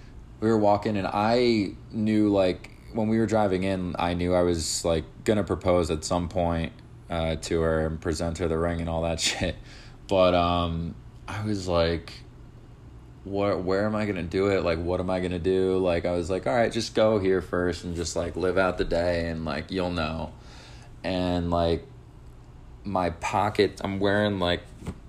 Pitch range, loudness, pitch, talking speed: 85-100 Hz, -26 LUFS, 90 Hz, 190 wpm